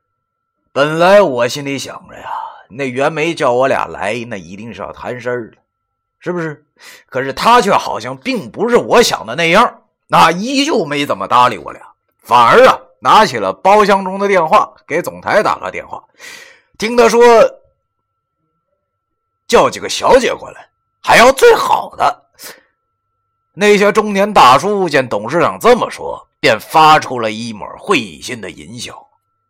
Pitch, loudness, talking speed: 190 Hz, -12 LUFS, 220 characters per minute